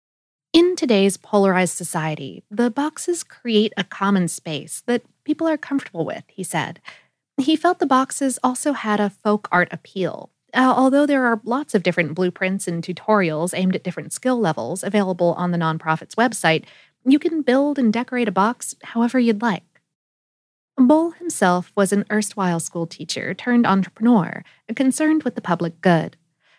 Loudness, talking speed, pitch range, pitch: -20 LUFS, 160 wpm, 175-255 Hz, 205 Hz